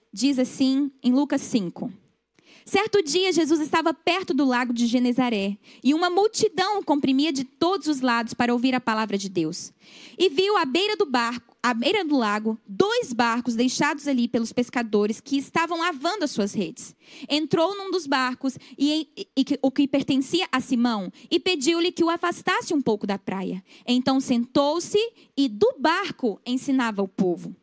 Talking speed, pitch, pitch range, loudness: 170 wpm, 275 Hz, 240-335 Hz, -24 LUFS